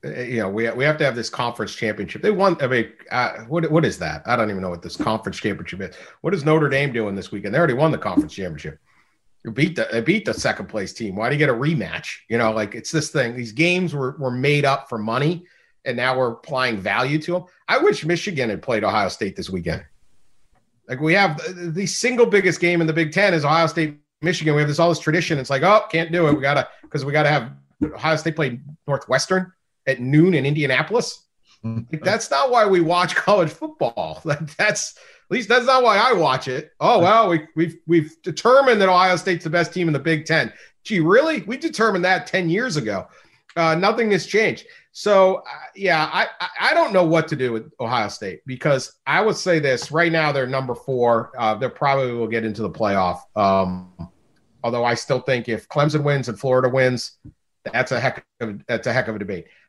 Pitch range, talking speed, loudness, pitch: 125-180 Hz, 230 wpm, -20 LUFS, 155 Hz